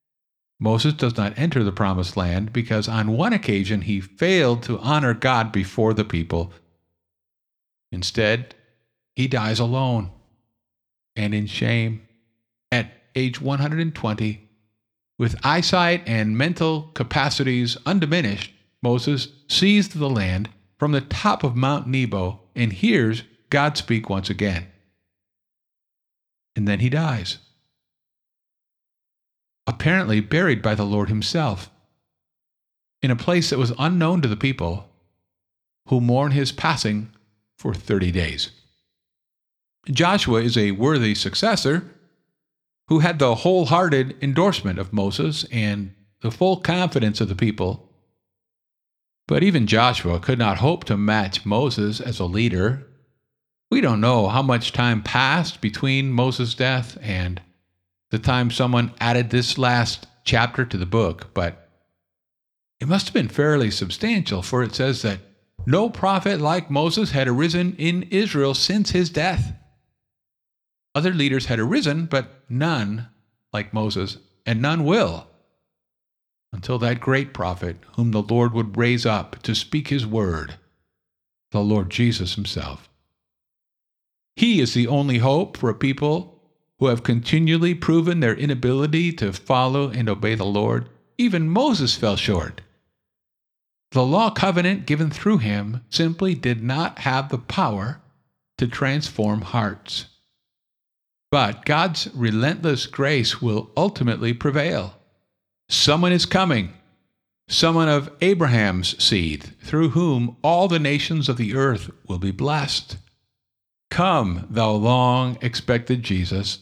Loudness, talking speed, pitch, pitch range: -21 LUFS, 130 wpm, 115 Hz, 100-145 Hz